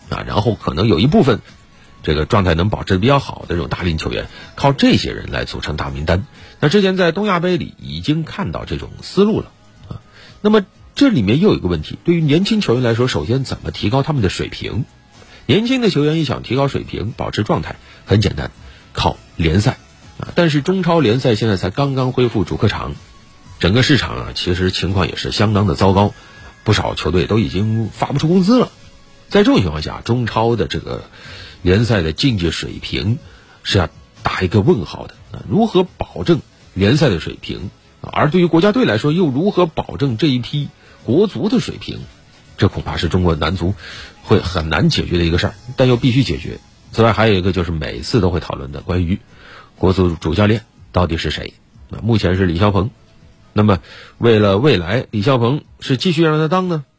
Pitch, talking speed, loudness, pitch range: 110 Hz, 295 characters per minute, -17 LUFS, 95-140 Hz